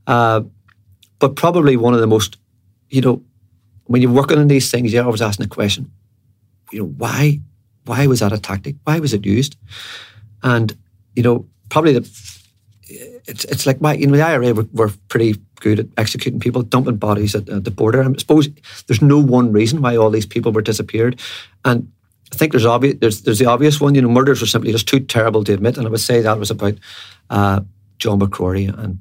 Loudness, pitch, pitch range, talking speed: -16 LUFS, 115 Hz, 105-130 Hz, 210 wpm